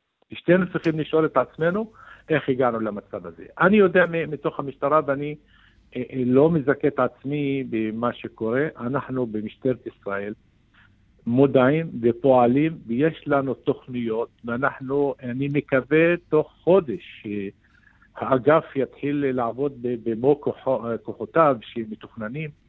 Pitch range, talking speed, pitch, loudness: 115-150 Hz, 105 wpm, 135 Hz, -23 LUFS